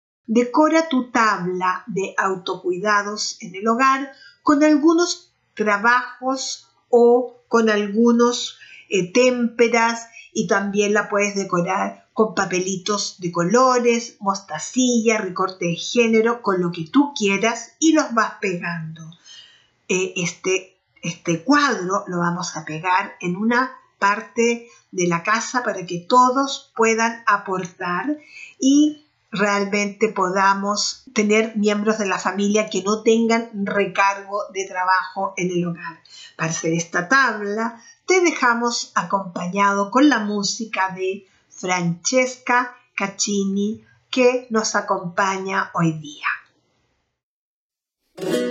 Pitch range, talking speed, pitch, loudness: 190-240 Hz, 115 wpm, 210 Hz, -20 LUFS